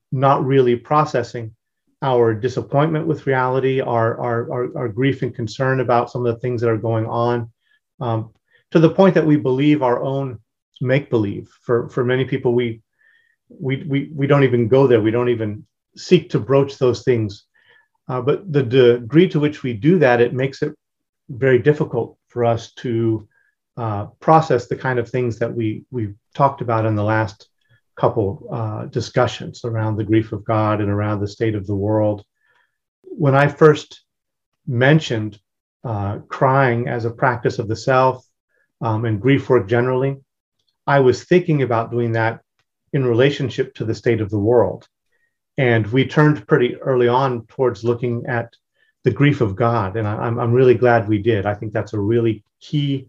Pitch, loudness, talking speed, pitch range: 125 Hz, -18 LUFS, 175 wpm, 115-140 Hz